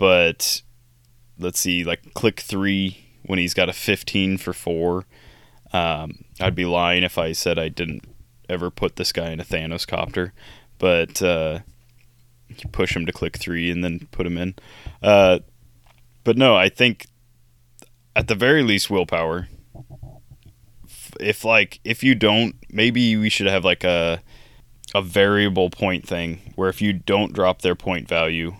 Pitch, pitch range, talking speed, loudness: 100 Hz, 90-120 Hz, 160 wpm, -20 LUFS